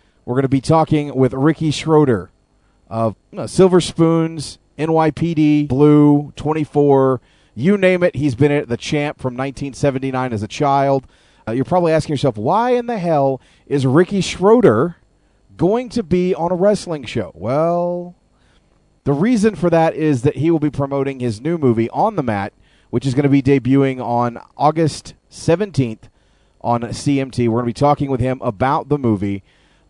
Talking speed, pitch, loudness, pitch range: 170 wpm, 140 Hz, -17 LUFS, 125-160 Hz